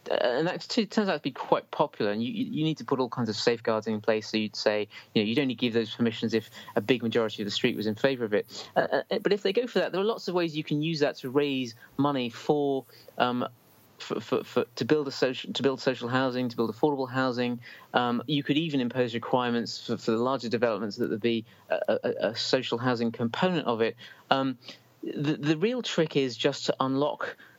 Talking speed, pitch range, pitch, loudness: 240 wpm, 115-150 Hz, 130 Hz, -28 LUFS